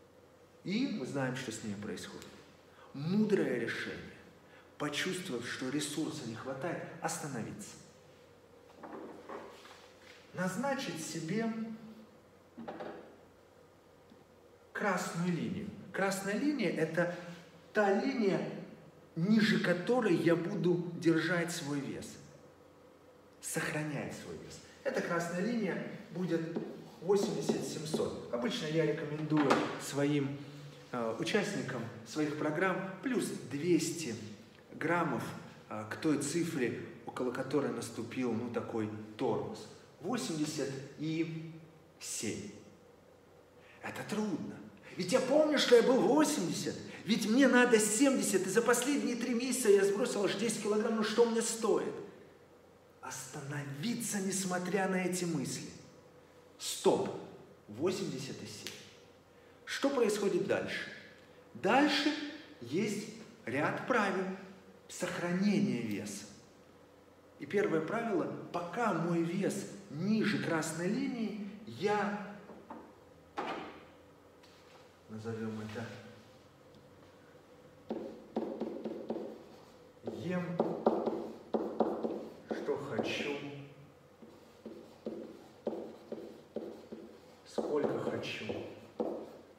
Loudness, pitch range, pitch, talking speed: -34 LUFS, 150-210 Hz, 175 Hz, 80 wpm